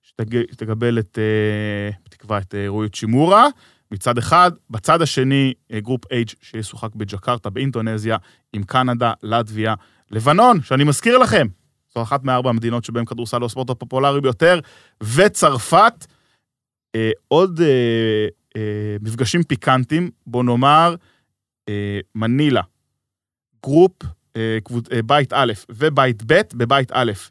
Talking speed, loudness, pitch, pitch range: 120 wpm, -18 LUFS, 120 Hz, 110-135 Hz